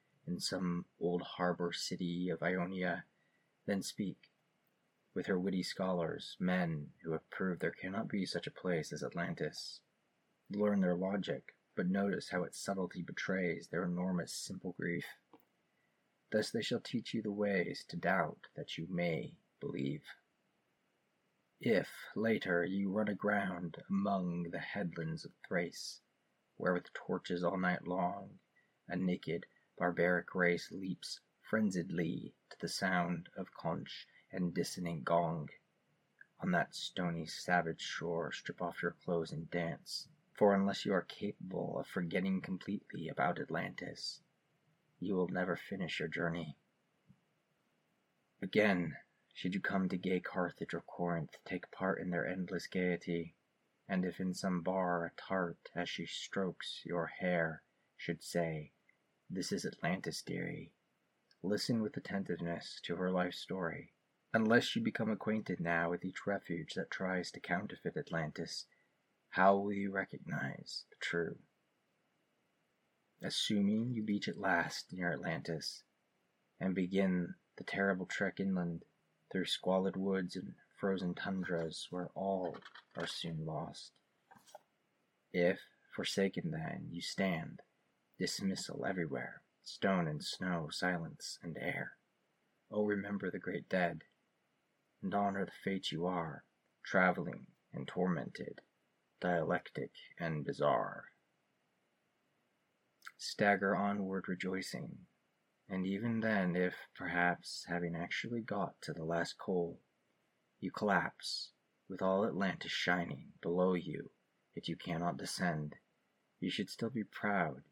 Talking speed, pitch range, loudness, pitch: 130 wpm, 85-100 Hz, -38 LUFS, 90 Hz